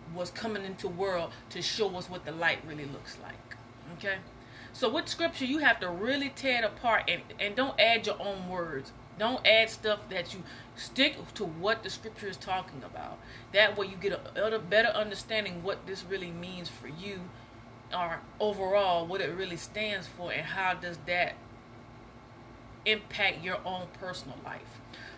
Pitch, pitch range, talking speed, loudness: 180 Hz, 135-210 Hz, 175 wpm, -31 LUFS